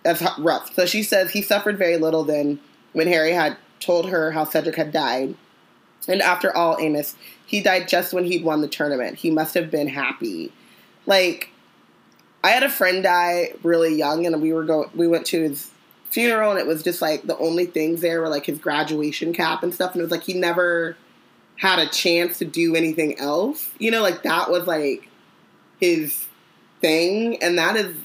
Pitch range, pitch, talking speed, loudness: 160-185 Hz, 170 Hz, 200 wpm, -21 LUFS